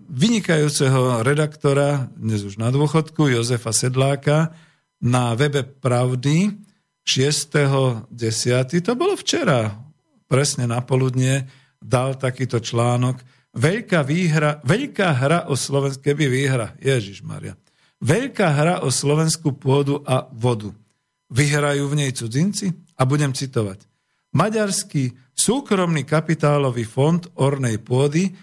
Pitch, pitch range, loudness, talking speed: 140 Hz, 125-160 Hz, -20 LUFS, 110 wpm